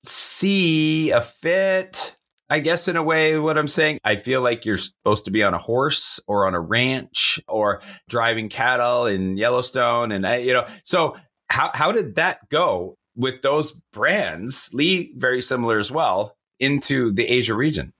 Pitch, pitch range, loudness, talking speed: 130 Hz, 115-155 Hz, -20 LUFS, 175 wpm